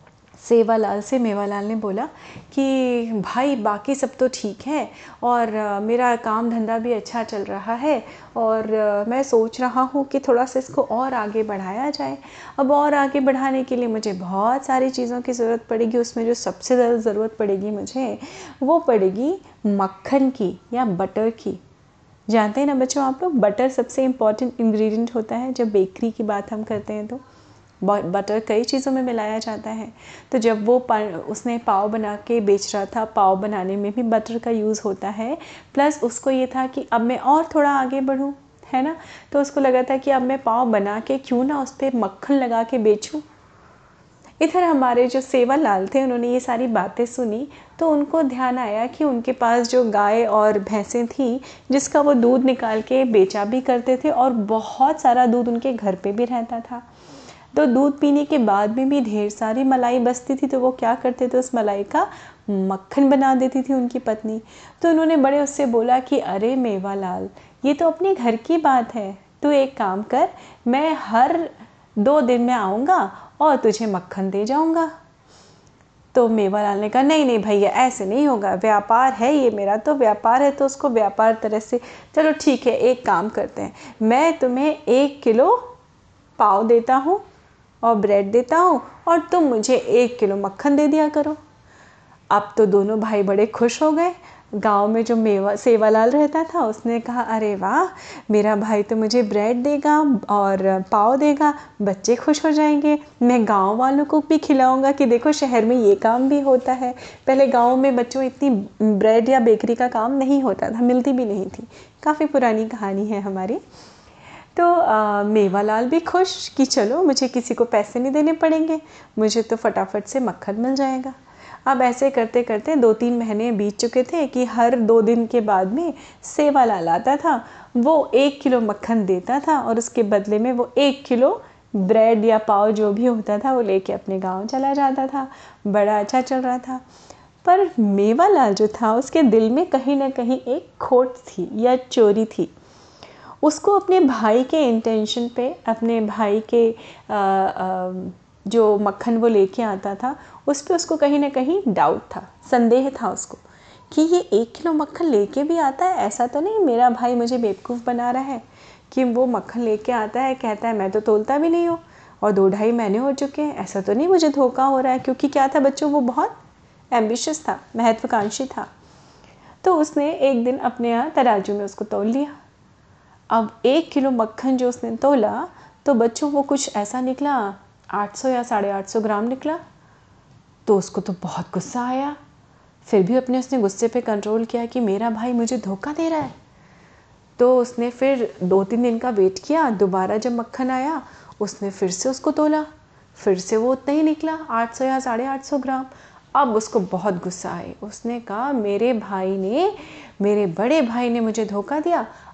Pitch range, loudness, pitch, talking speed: 215-275 Hz, -20 LUFS, 245 Hz, 185 wpm